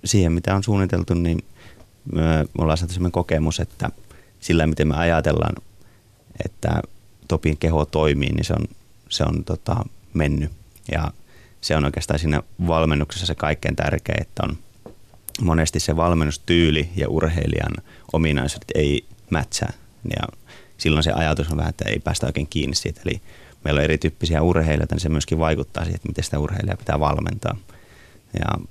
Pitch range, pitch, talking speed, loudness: 75-95 Hz, 80 Hz, 155 wpm, -22 LUFS